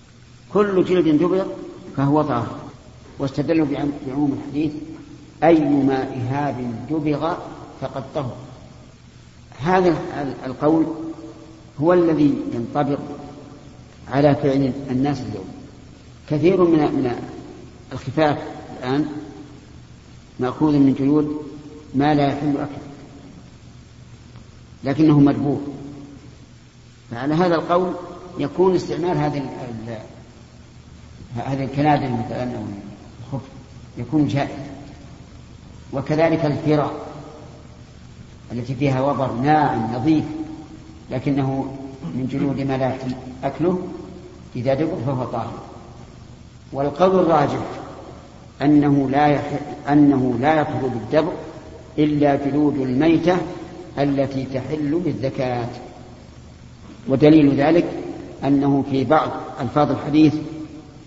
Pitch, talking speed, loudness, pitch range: 145 Hz, 85 wpm, -20 LUFS, 130-155 Hz